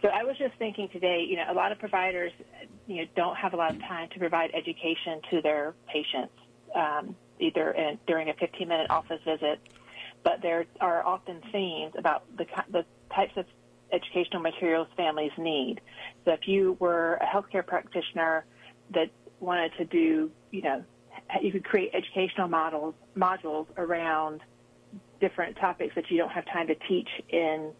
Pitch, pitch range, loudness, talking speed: 170 Hz, 160-185 Hz, -30 LUFS, 170 wpm